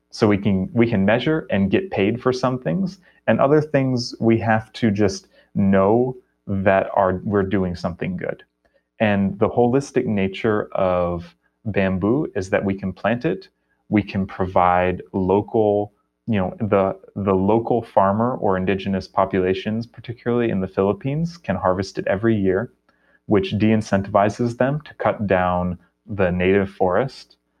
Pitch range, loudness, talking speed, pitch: 95-115 Hz, -21 LUFS, 150 wpm, 100 Hz